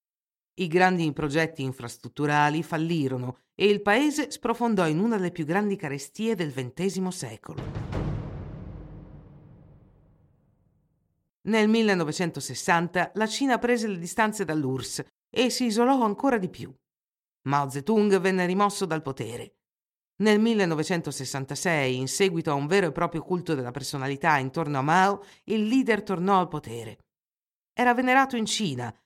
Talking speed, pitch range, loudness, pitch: 130 wpm, 140-205 Hz, -26 LUFS, 175 Hz